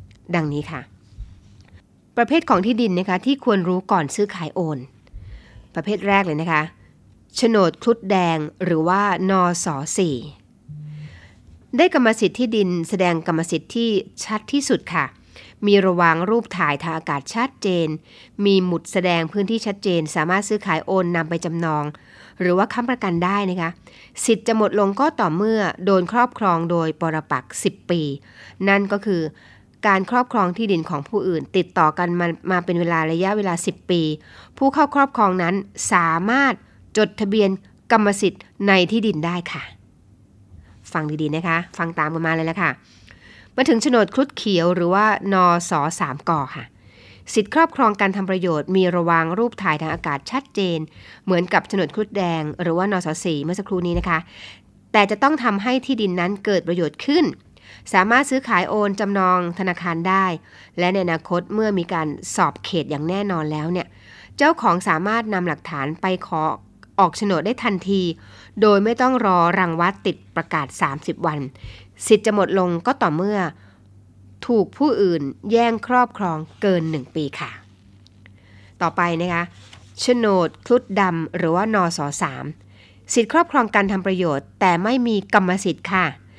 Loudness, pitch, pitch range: -20 LUFS, 180 Hz, 155-205 Hz